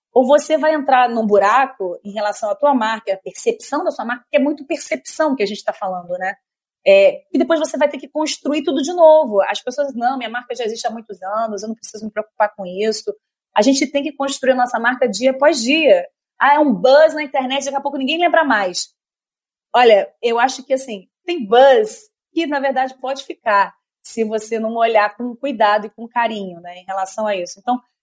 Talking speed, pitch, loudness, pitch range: 220 wpm, 260 Hz, -16 LUFS, 215-295 Hz